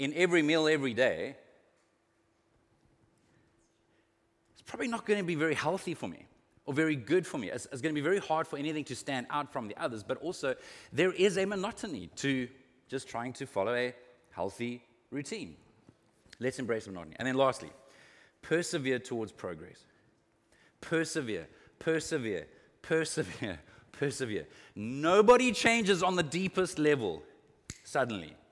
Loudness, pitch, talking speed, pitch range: -32 LUFS, 145 Hz, 140 wpm, 125-175 Hz